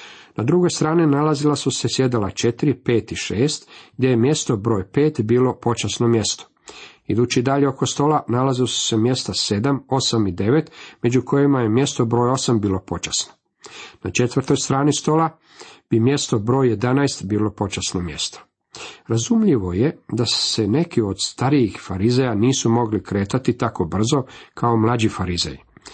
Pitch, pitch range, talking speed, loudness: 120 Hz, 110-140 Hz, 155 wpm, -20 LUFS